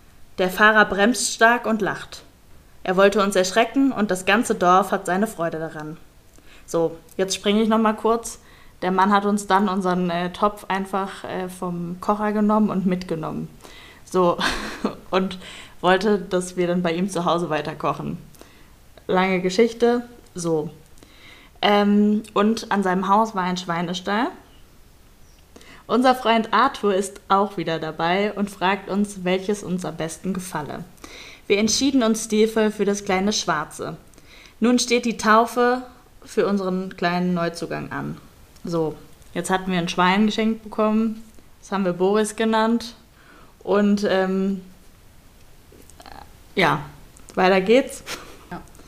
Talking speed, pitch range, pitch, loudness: 135 wpm, 175-215 Hz, 190 Hz, -21 LUFS